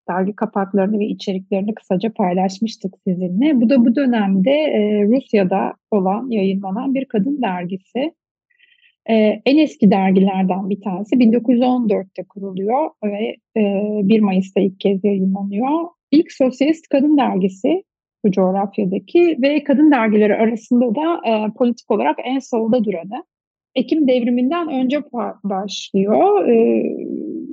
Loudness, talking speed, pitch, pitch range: -17 LUFS, 120 wpm, 225 Hz, 200-270 Hz